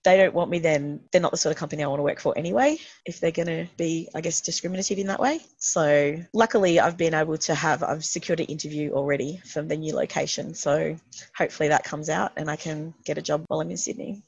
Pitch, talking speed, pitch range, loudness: 165 Hz, 250 wpm, 150-180 Hz, -25 LUFS